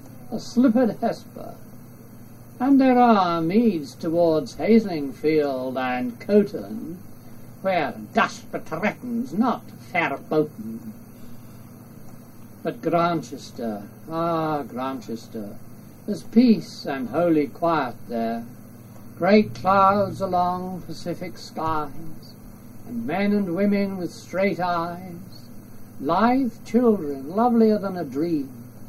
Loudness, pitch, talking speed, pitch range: -23 LUFS, 155 Hz, 95 wpm, 115-195 Hz